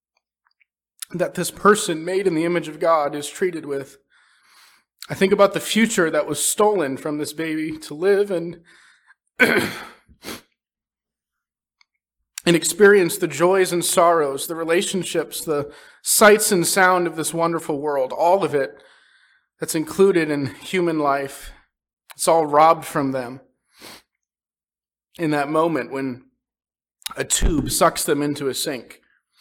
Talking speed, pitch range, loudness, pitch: 135 wpm, 150-185 Hz, -19 LUFS, 165 Hz